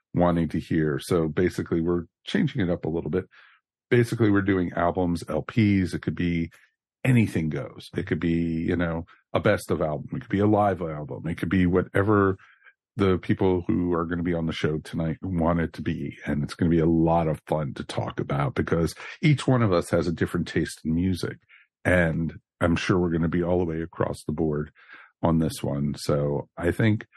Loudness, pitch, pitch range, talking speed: -25 LUFS, 85 Hz, 80-95 Hz, 215 wpm